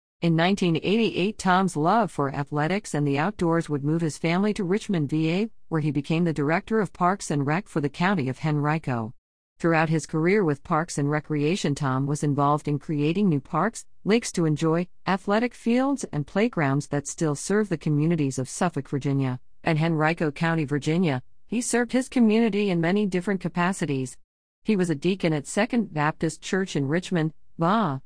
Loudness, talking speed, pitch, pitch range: -25 LUFS, 175 wpm, 165 Hz, 150-190 Hz